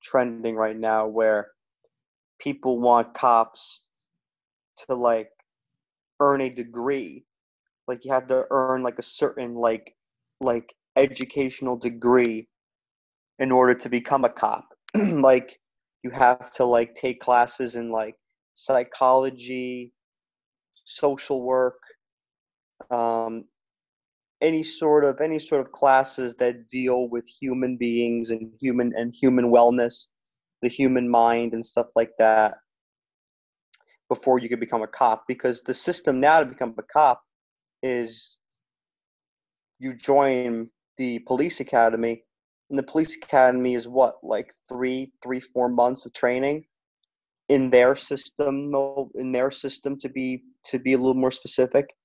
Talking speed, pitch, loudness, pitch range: 130 wpm, 125 Hz, -23 LUFS, 120-130 Hz